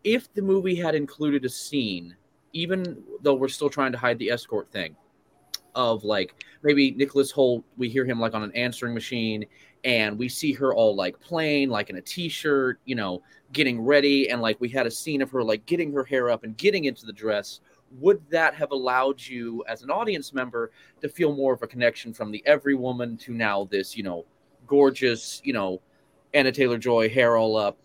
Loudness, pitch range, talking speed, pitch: -25 LUFS, 115-145 Hz, 210 wpm, 130 Hz